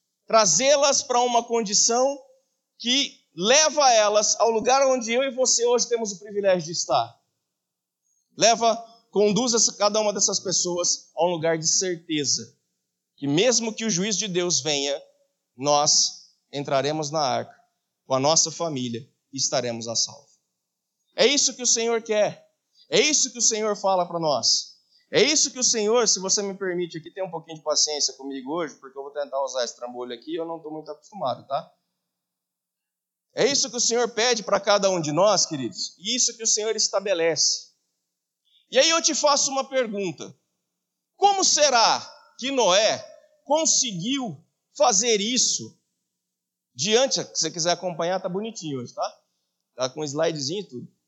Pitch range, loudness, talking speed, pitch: 160-245 Hz, -22 LUFS, 165 wpm, 205 Hz